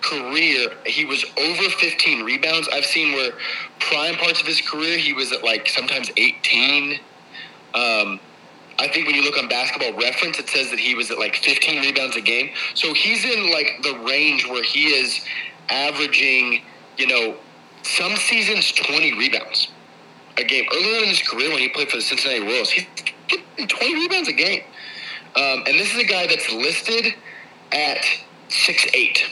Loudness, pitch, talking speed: -18 LUFS, 150 Hz, 175 wpm